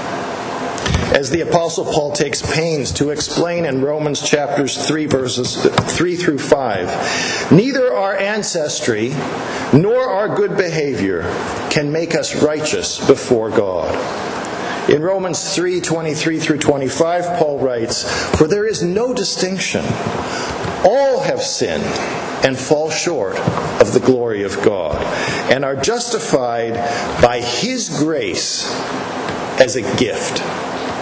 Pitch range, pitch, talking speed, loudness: 145-190 Hz, 160 Hz, 120 wpm, -17 LUFS